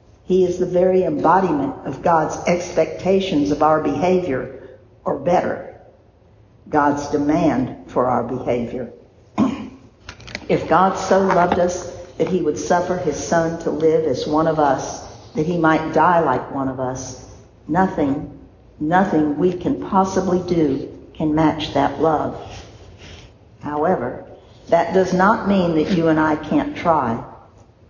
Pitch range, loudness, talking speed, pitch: 140-180 Hz, -19 LUFS, 140 wpm, 155 Hz